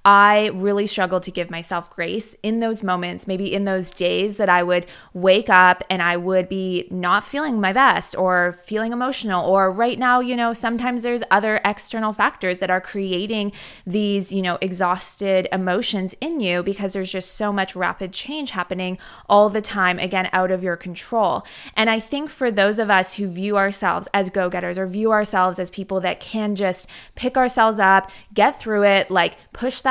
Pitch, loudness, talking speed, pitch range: 195 Hz, -20 LUFS, 195 wpm, 185-215 Hz